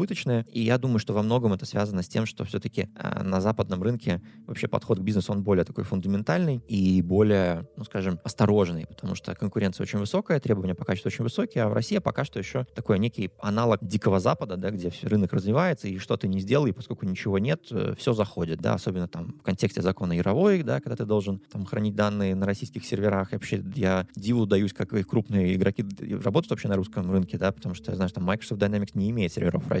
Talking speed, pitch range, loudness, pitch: 215 wpm, 95-115 Hz, -27 LUFS, 105 Hz